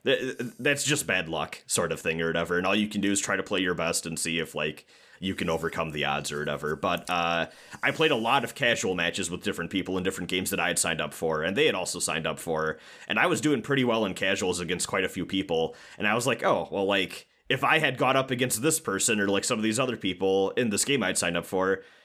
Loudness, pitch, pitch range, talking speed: -27 LUFS, 95 Hz, 85-125 Hz, 275 wpm